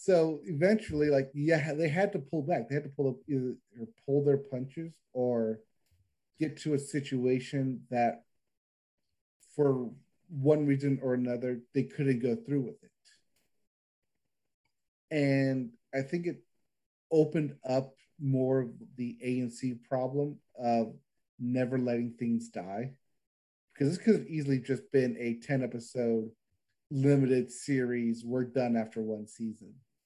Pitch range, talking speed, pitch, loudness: 120-145 Hz, 140 wpm, 130 Hz, -32 LUFS